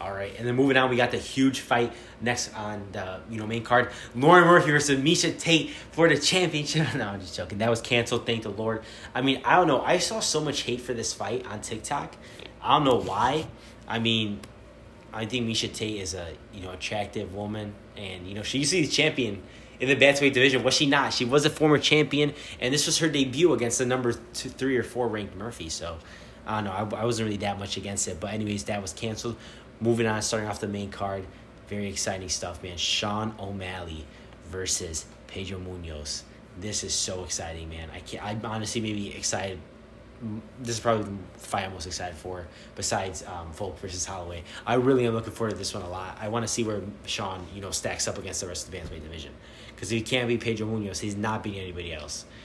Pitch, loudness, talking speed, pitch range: 110 Hz, -26 LUFS, 230 wpm, 95-120 Hz